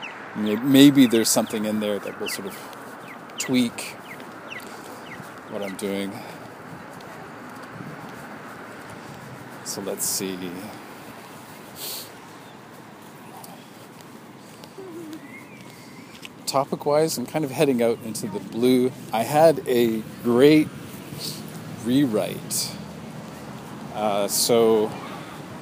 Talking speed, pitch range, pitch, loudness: 75 wpm, 110-150 Hz, 125 Hz, -22 LUFS